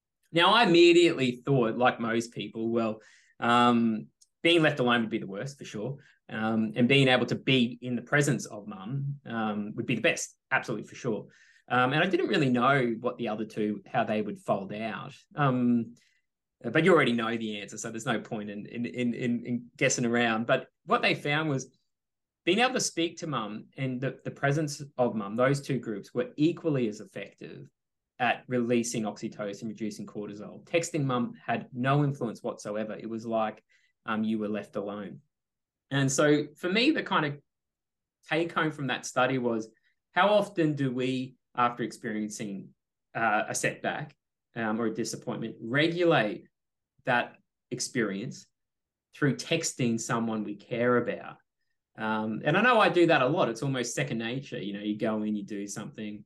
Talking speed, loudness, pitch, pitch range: 180 wpm, -28 LUFS, 120 Hz, 110-145 Hz